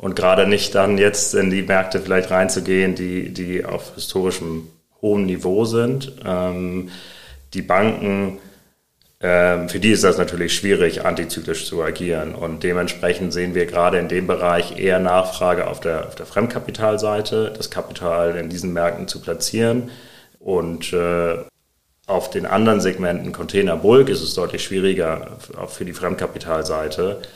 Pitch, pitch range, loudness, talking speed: 90 Hz, 85-100 Hz, -20 LUFS, 150 wpm